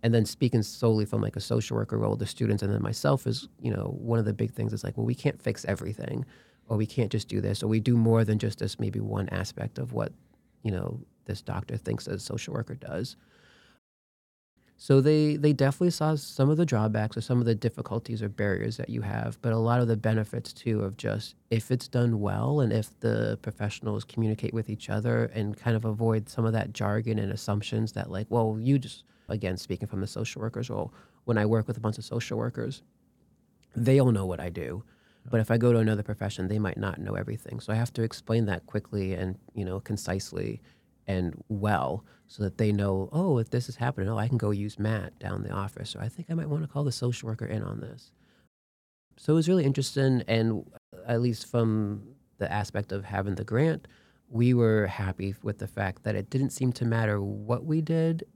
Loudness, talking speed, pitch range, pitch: -29 LUFS, 225 wpm, 105-120 Hz, 115 Hz